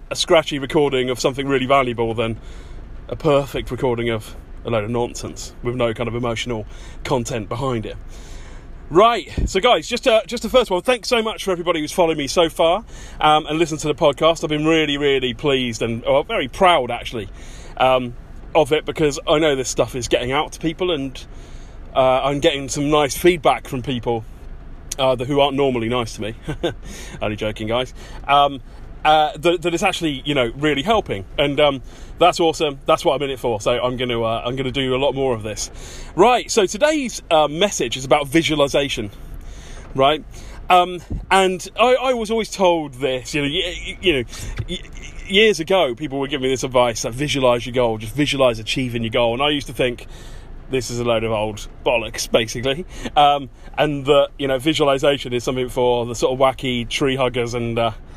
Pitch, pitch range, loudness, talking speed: 135 Hz, 120-155 Hz, -19 LUFS, 200 wpm